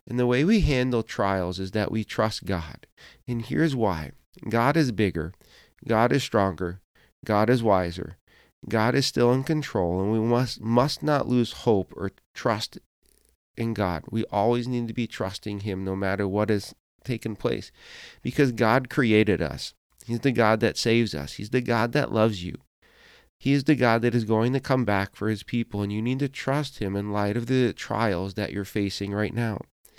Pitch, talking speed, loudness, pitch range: 110 Hz, 195 wpm, -25 LUFS, 100-125 Hz